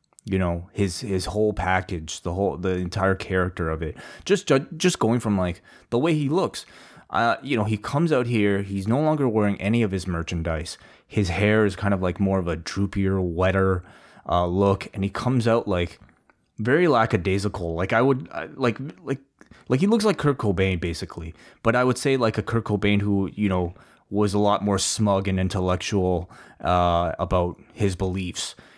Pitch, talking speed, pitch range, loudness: 100 Hz, 190 wpm, 90-110 Hz, -24 LUFS